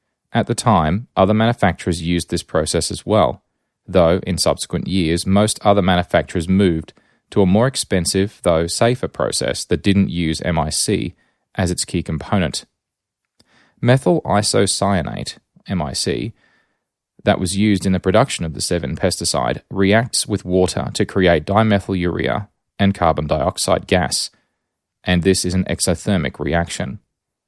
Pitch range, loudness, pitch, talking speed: 85-105 Hz, -18 LUFS, 95 Hz, 140 wpm